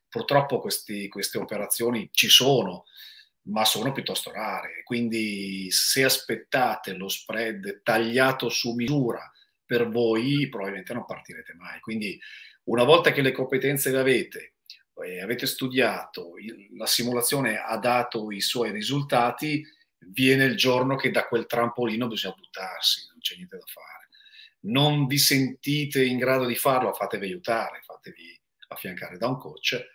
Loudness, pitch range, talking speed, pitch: -24 LUFS, 115-140 Hz, 140 wpm, 125 Hz